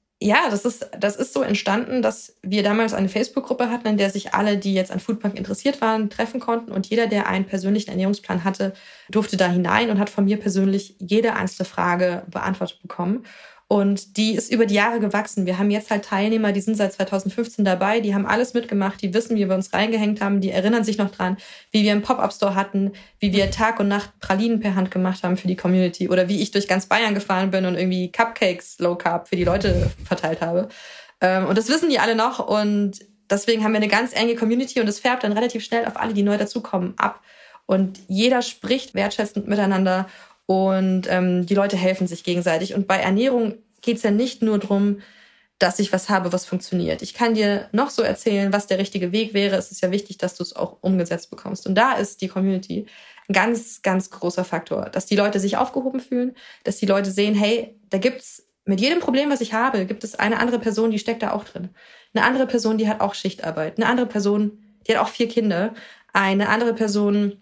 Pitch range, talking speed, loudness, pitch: 190-225 Hz, 215 wpm, -21 LUFS, 205 Hz